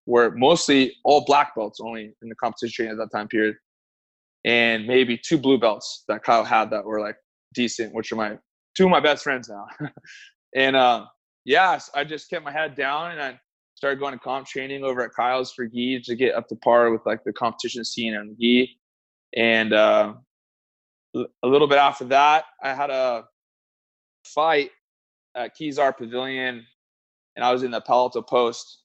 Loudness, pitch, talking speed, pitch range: -22 LUFS, 125 Hz, 185 wpm, 115-140 Hz